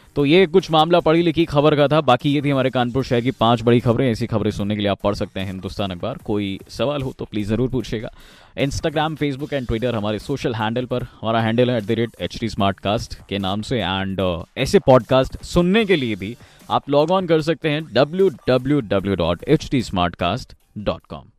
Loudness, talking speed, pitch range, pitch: -20 LUFS, 185 wpm, 105-145 Hz, 125 Hz